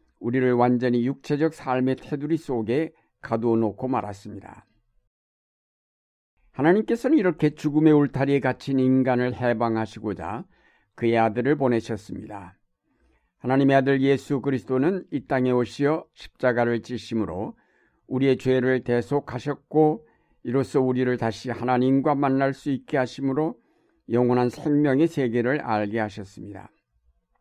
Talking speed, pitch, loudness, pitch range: 300 characters per minute, 130 Hz, -24 LUFS, 115-145 Hz